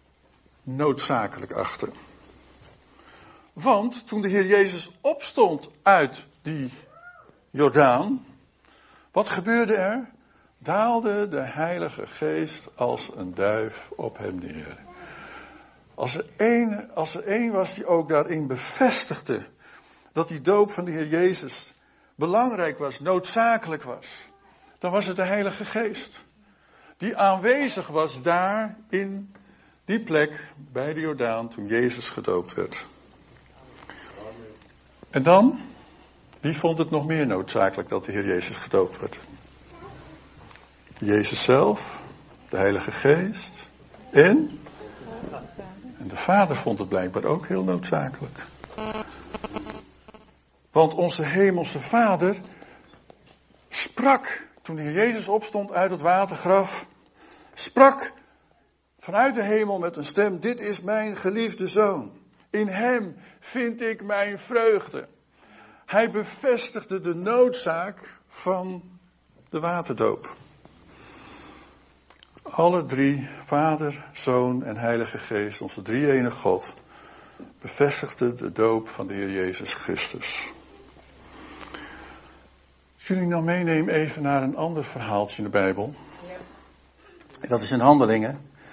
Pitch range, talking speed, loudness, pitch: 135-210 Hz, 110 wpm, -24 LUFS, 170 Hz